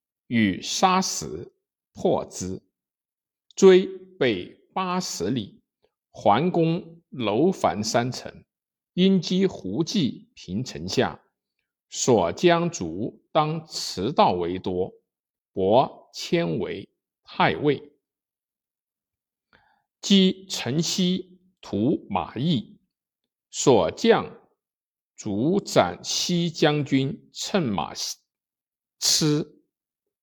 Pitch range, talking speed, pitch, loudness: 155-190 Hz, 105 characters per minute, 180 Hz, -24 LUFS